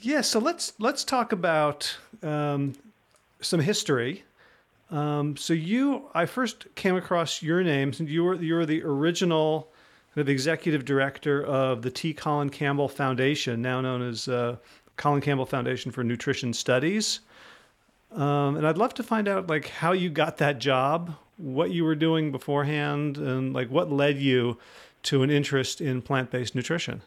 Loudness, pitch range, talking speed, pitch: -26 LUFS, 135-170 Hz, 165 wpm, 145 Hz